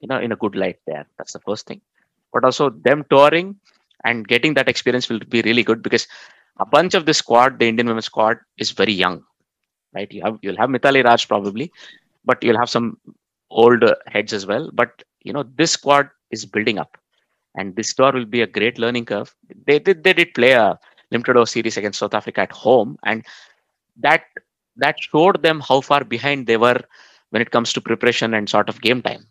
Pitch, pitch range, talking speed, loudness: 120 Hz, 115-140 Hz, 215 wpm, -17 LUFS